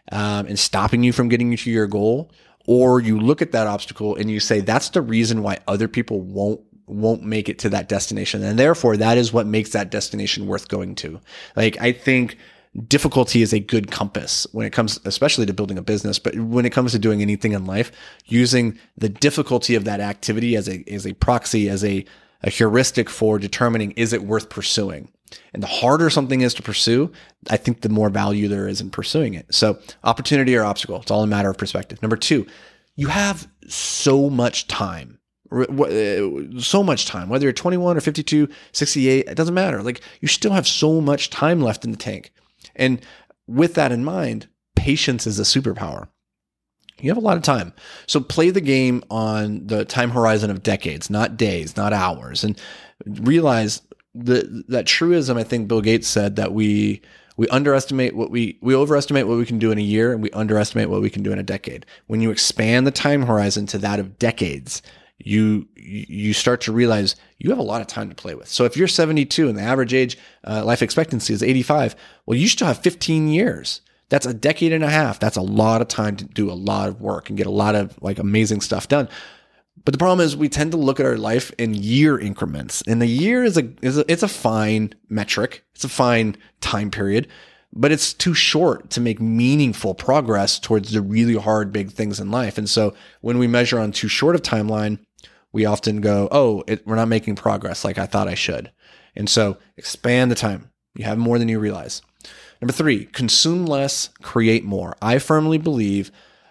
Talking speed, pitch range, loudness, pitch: 205 wpm, 105-130 Hz, -19 LUFS, 115 Hz